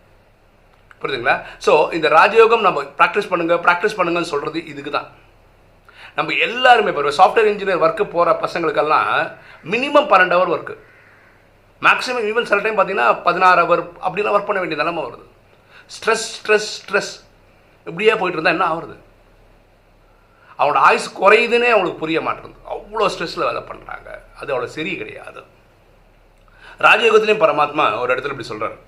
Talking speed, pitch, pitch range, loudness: 135 wpm, 185 Hz, 155-215 Hz, -16 LUFS